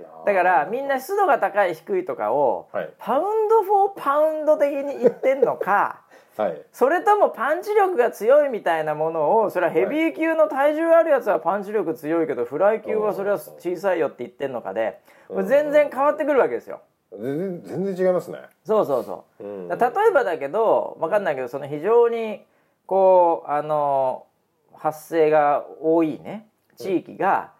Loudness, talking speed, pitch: -21 LUFS, 340 characters per minute, 220 Hz